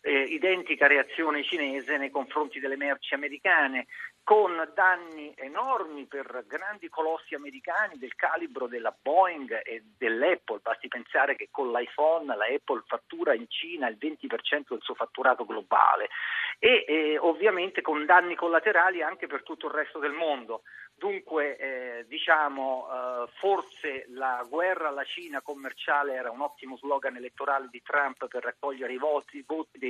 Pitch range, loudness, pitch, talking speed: 135-185 Hz, -28 LUFS, 150 Hz, 150 wpm